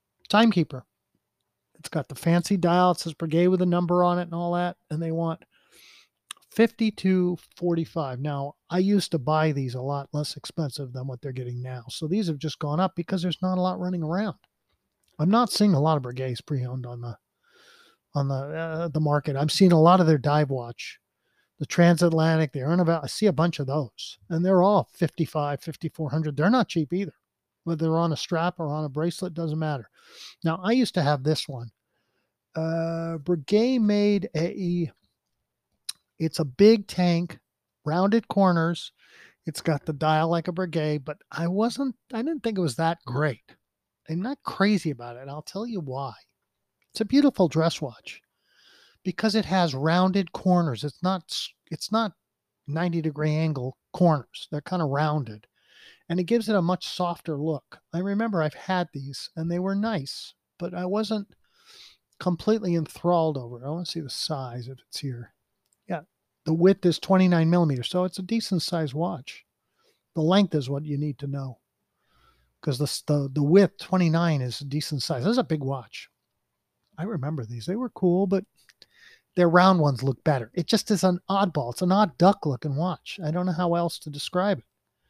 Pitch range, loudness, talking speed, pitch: 150-185 Hz, -25 LUFS, 190 wpm, 165 Hz